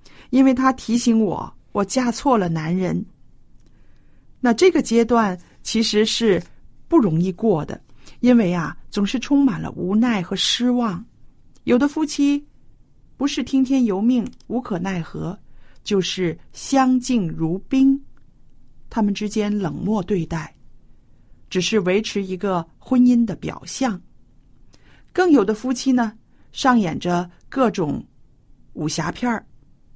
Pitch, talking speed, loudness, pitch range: 220 Hz, 185 characters per minute, -20 LUFS, 185-255 Hz